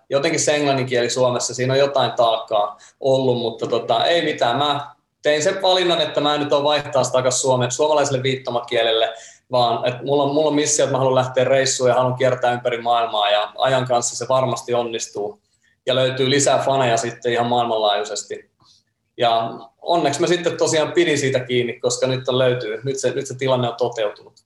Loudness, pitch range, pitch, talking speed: -19 LUFS, 120-145 Hz, 130 Hz, 180 wpm